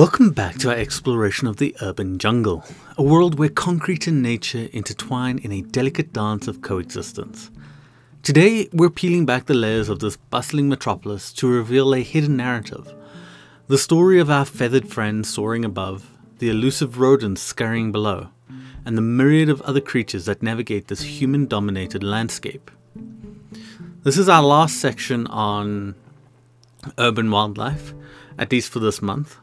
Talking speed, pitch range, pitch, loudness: 155 wpm, 110-140 Hz, 125 Hz, -20 LUFS